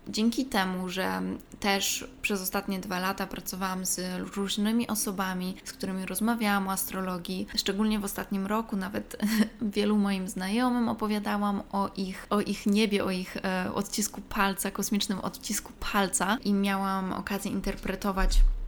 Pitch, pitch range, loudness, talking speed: 200 Hz, 190-210 Hz, -29 LUFS, 135 wpm